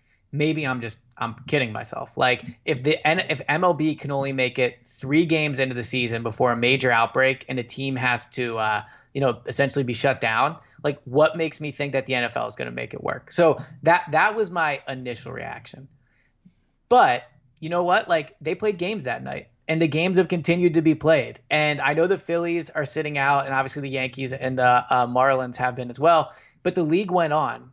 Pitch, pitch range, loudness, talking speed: 135 Hz, 125-155 Hz, -22 LUFS, 215 wpm